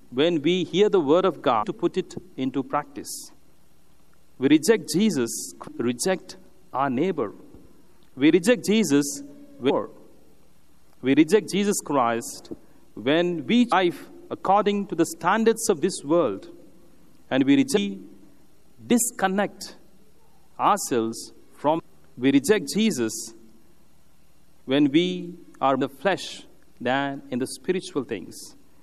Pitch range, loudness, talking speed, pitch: 140-215 Hz, -23 LUFS, 120 wpm, 180 Hz